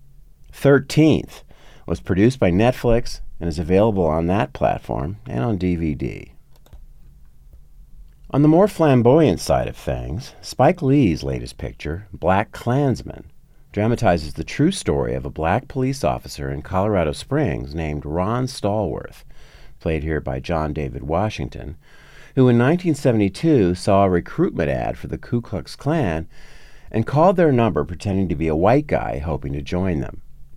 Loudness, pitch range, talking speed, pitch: -20 LUFS, 75-120 Hz, 145 wpm, 95 Hz